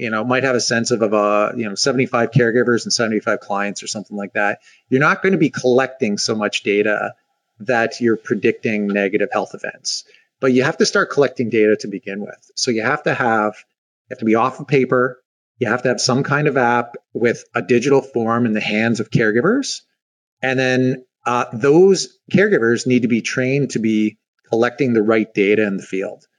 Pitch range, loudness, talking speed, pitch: 110-130 Hz, -18 LUFS, 210 wpm, 120 Hz